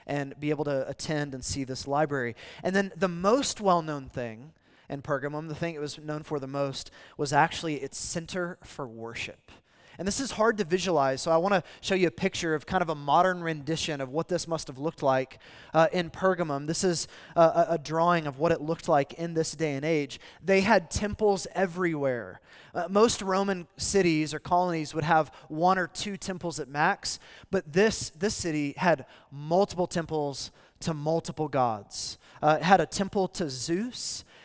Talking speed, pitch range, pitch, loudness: 195 wpm, 140-180 Hz, 160 Hz, -28 LUFS